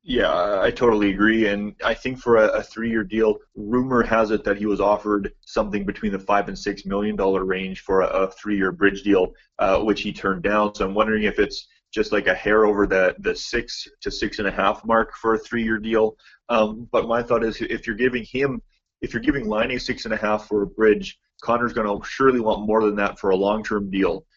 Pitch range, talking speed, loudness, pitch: 100-115 Hz, 240 wpm, -22 LUFS, 105 Hz